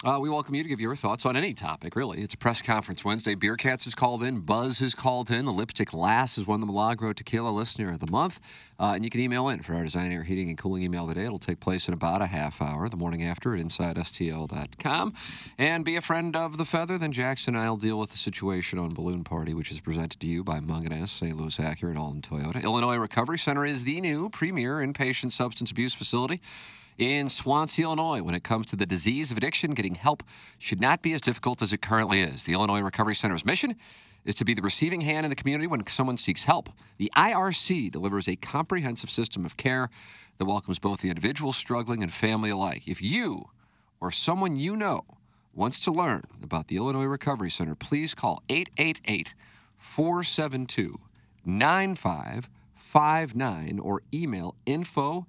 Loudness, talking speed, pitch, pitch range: -28 LUFS, 205 wpm, 115 Hz, 95-140 Hz